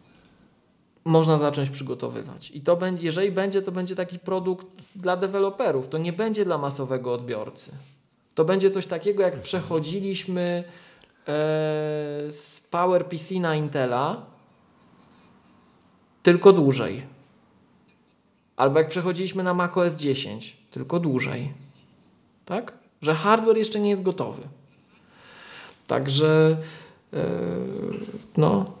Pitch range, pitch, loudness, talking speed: 150-190 Hz, 175 Hz, -24 LUFS, 110 wpm